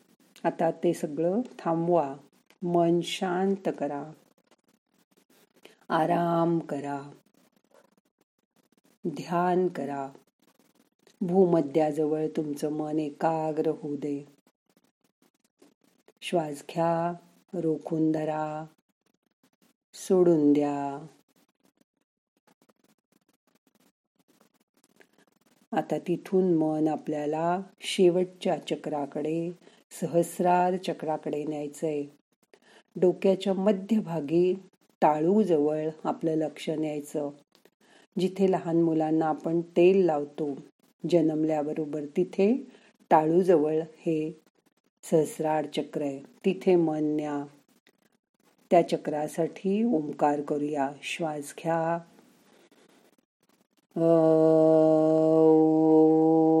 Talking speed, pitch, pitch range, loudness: 65 wpm, 160 Hz, 155-180 Hz, -27 LUFS